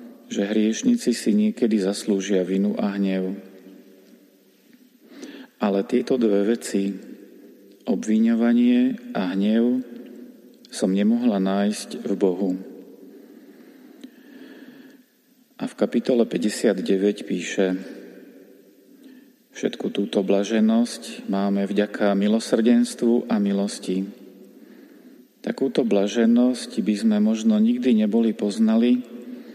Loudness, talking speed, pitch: -22 LUFS, 85 wpm, 115 Hz